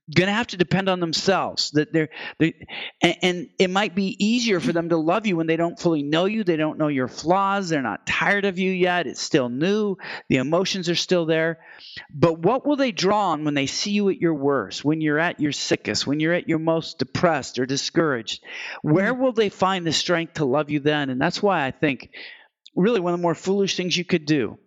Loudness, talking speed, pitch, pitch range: -22 LUFS, 235 wpm, 170 Hz, 155-190 Hz